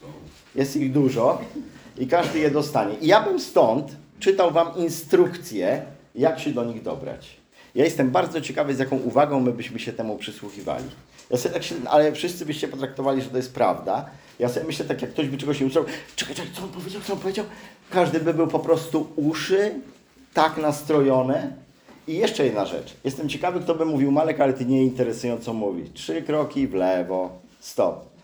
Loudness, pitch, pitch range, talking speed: -23 LUFS, 150 Hz, 130-170 Hz, 190 wpm